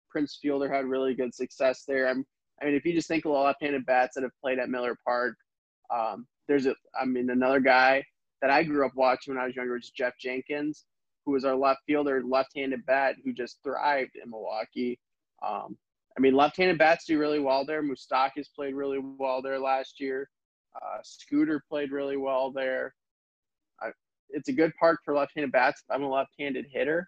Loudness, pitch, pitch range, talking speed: -28 LUFS, 135 Hz, 130-145 Hz, 200 wpm